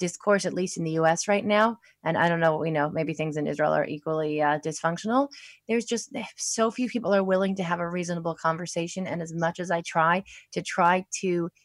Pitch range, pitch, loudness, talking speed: 160-200 Hz, 175 Hz, -26 LUFS, 230 wpm